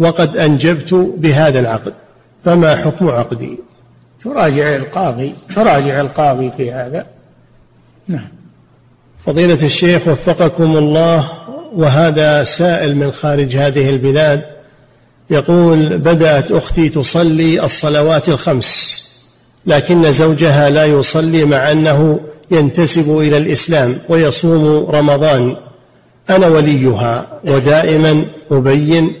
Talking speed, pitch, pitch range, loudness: 90 wpm, 150 Hz, 140-165 Hz, -11 LUFS